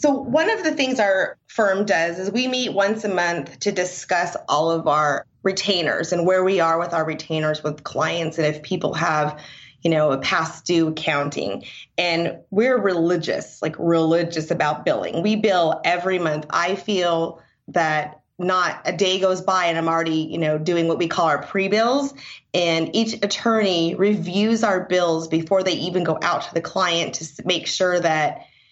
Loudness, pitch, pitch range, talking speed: -21 LUFS, 175 Hz, 160-195 Hz, 185 wpm